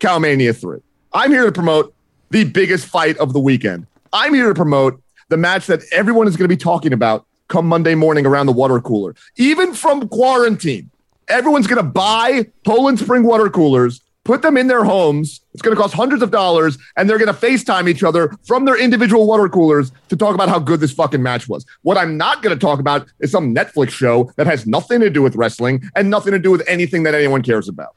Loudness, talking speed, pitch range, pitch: -14 LUFS, 225 wpm, 140-220 Hz, 170 Hz